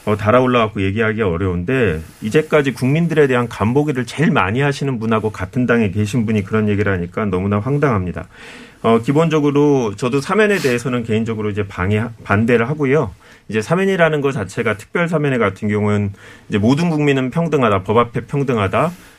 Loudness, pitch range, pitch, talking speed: -17 LUFS, 105-145 Hz, 120 Hz, 415 characters per minute